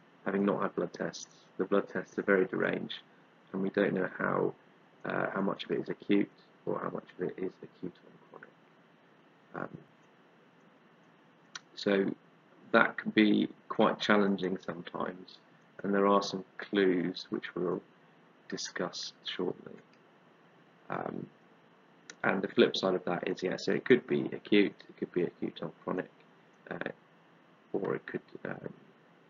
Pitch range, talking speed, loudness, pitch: 95-100 Hz, 145 wpm, -32 LUFS, 100 Hz